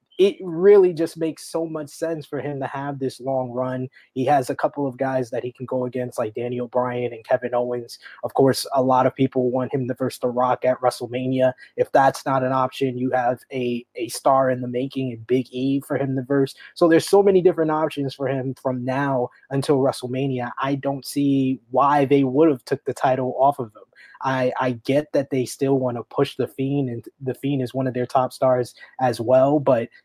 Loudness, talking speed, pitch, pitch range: -22 LUFS, 225 wpm, 130 Hz, 125-140 Hz